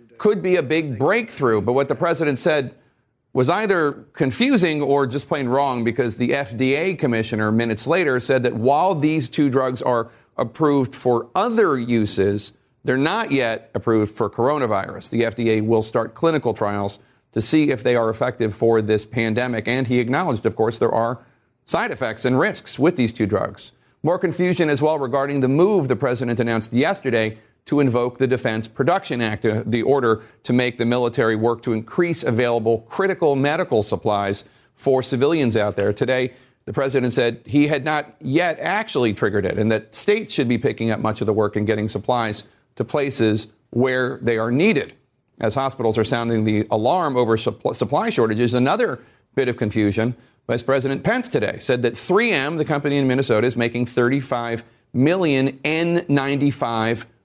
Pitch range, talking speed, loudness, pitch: 115-140 Hz, 175 wpm, -20 LUFS, 125 Hz